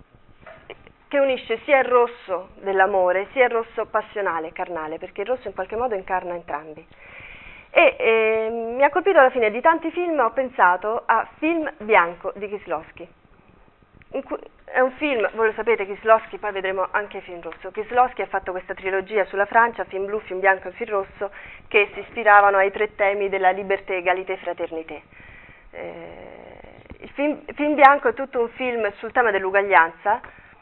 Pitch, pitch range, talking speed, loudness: 205 Hz, 190-240 Hz, 165 wpm, -21 LUFS